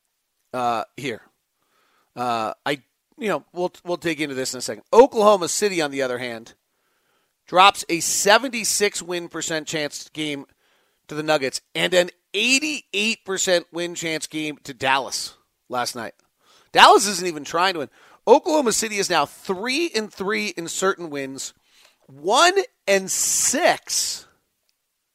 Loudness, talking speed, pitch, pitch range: -21 LUFS, 145 wpm, 180 Hz, 155-210 Hz